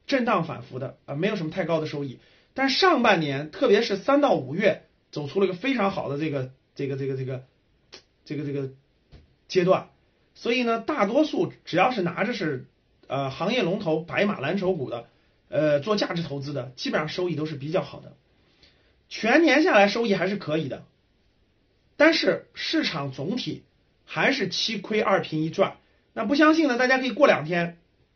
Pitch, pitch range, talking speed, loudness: 185 Hz, 140-230 Hz, 275 characters per minute, -24 LUFS